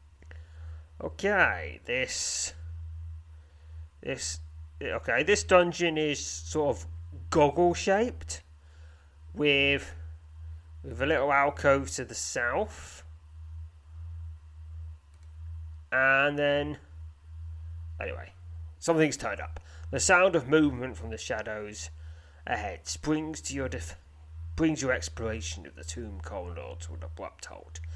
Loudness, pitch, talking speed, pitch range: -28 LUFS, 80 Hz, 105 wpm, 80-110 Hz